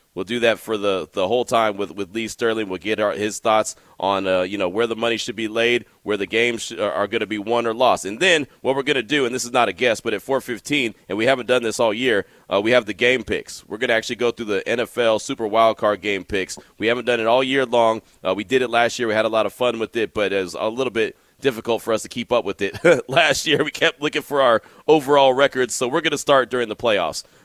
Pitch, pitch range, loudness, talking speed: 115 Hz, 110-125 Hz, -20 LUFS, 290 wpm